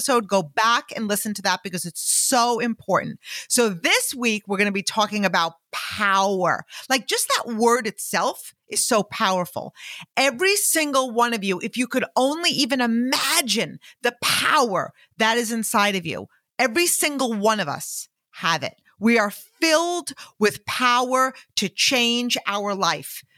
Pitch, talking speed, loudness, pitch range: 235 Hz, 160 wpm, -21 LUFS, 205-260 Hz